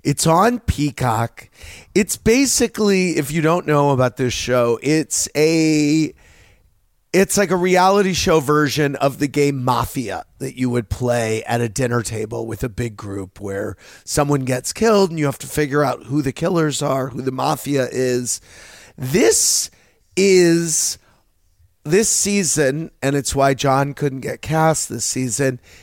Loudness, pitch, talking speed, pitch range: -18 LUFS, 140 Hz, 155 wpm, 120-160 Hz